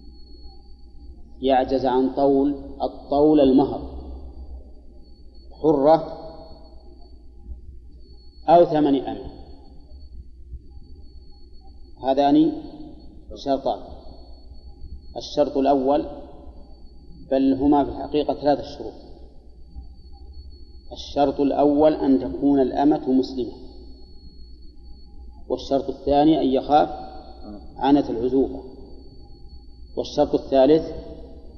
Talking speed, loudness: 65 wpm, -21 LUFS